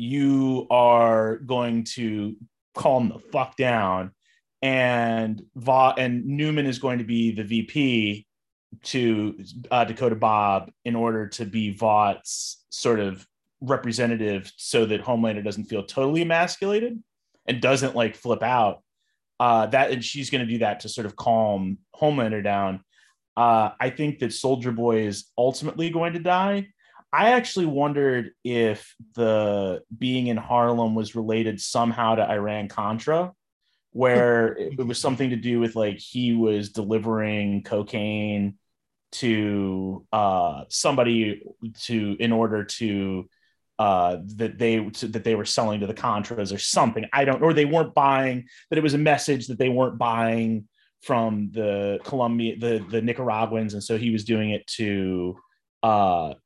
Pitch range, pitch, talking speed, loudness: 105-130 Hz, 115 Hz, 150 wpm, -24 LUFS